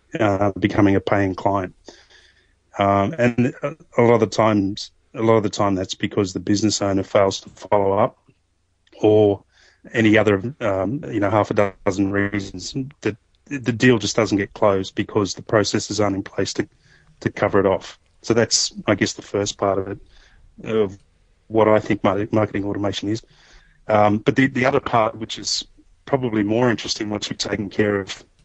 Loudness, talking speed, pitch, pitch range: -20 LUFS, 180 wpm, 105 Hz, 100-110 Hz